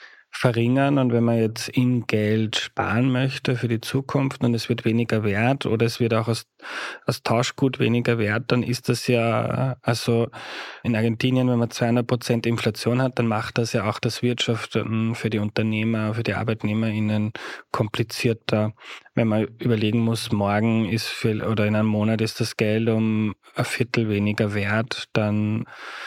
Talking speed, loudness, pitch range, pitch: 165 wpm, -23 LUFS, 110-120 Hz, 115 Hz